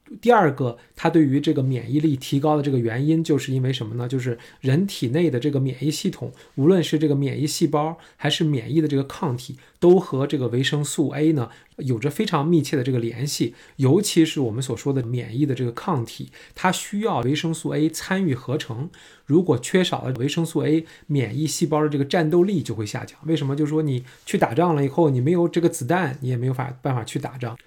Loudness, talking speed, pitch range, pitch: -22 LUFS, 335 characters per minute, 130-165 Hz, 150 Hz